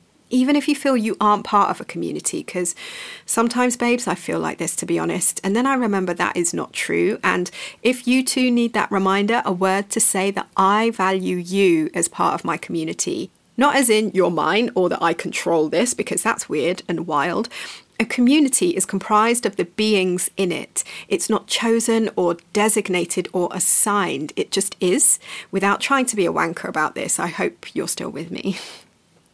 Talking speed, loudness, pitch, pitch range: 195 wpm, -20 LUFS, 205 Hz, 185-240 Hz